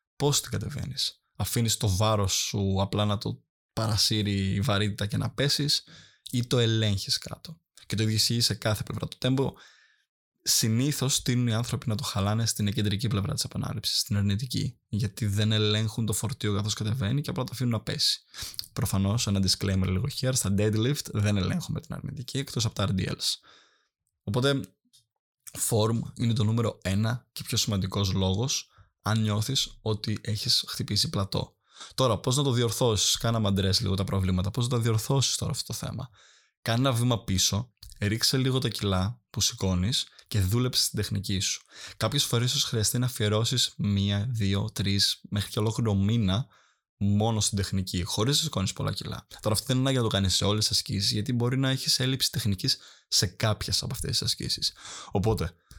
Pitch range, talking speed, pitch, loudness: 100-125 Hz, 180 wpm, 110 Hz, -27 LUFS